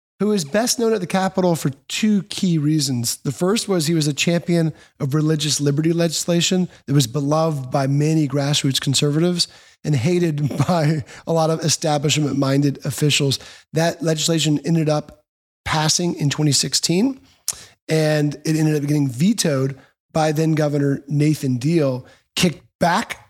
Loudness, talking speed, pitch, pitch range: -19 LUFS, 145 wpm, 155 Hz, 145-170 Hz